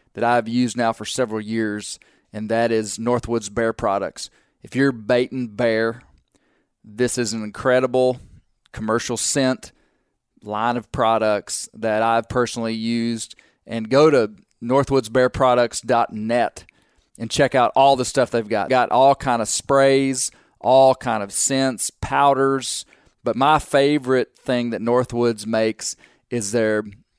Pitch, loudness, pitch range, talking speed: 120 Hz, -20 LUFS, 110-130 Hz, 135 wpm